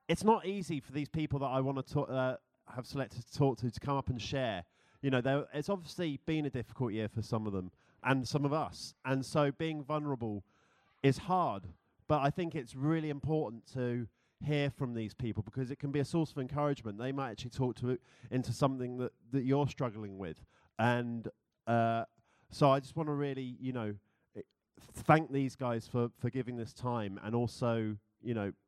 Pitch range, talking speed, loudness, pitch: 115-145 Hz, 205 wpm, -35 LUFS, 130 Hz